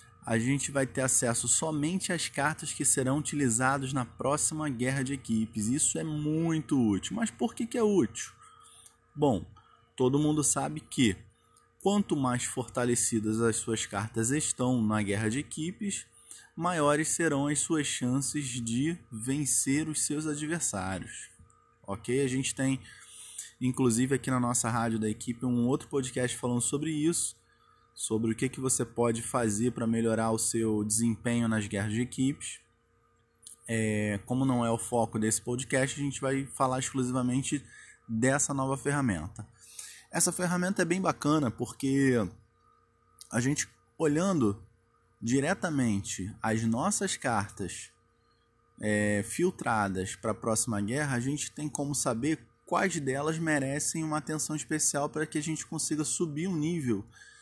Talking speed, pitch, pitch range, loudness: 145 wpm, 130 Hz, 115-150 Hz, -30 LUFS